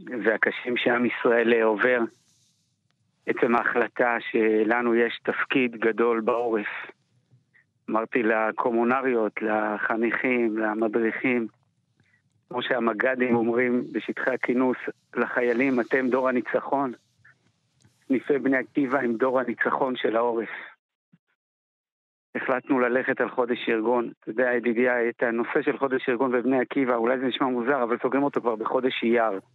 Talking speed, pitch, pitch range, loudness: 115 wpm, 120 Hz, 115-130 Hz, -24 LUFS